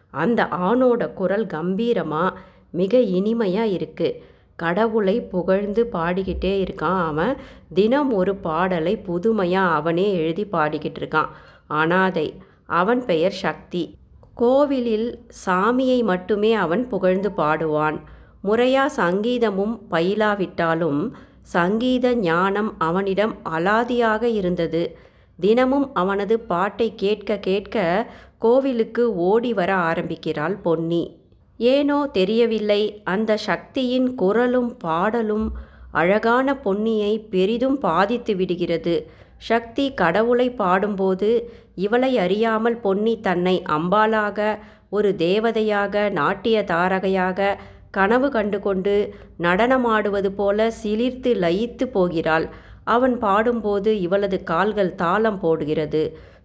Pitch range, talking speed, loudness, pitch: 180-230 Hz, 90 wpm, -21 LUFS, 205 Hz